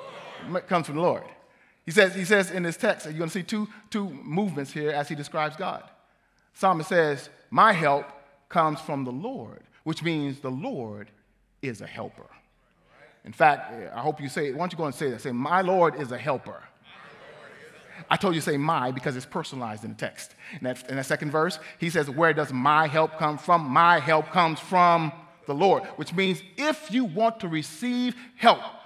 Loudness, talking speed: -25 LUFS, 200 wpm